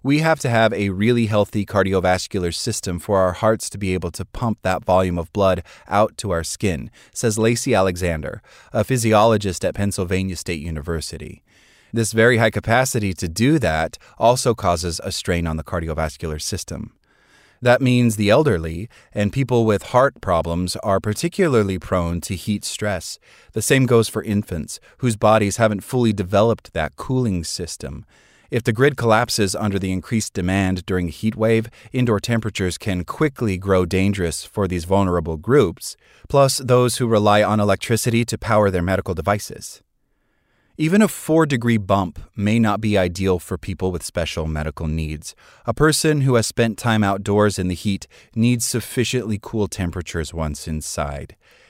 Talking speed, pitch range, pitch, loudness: 165 wpm, 90-115 Hz, 105 Hz, -20 LUFS